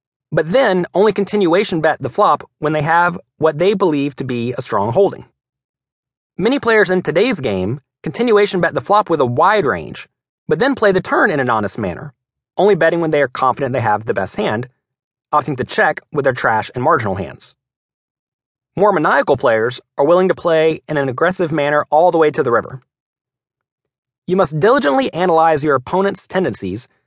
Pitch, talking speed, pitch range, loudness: 160 Hz, 185 wpm, 135-185 Hz, -16 LUFS